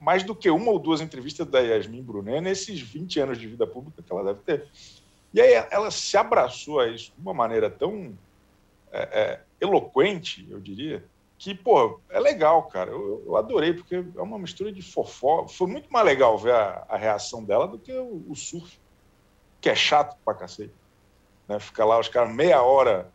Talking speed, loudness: 195 wpm, -24 LUFS